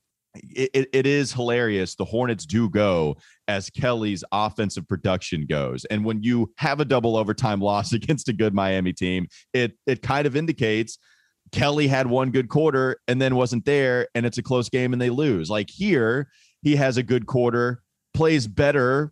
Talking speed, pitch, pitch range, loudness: 180 wpm, 125 Hz, 105-135 Hz, -23 LUFS